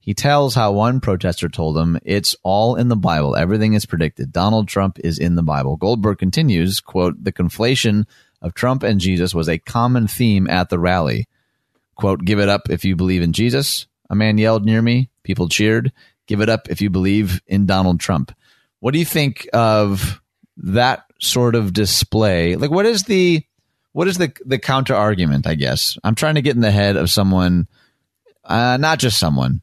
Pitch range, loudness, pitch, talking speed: 90-120 Hz, -17 LUFS, 105 Hz, 195 wpm